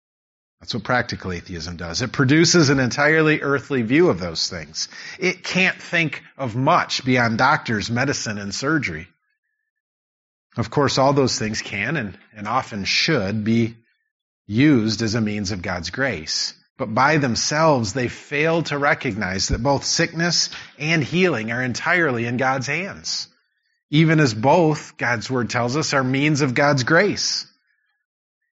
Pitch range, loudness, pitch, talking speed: 115-155 Hz, -20 LUFS, 135 Hz, 150 wpm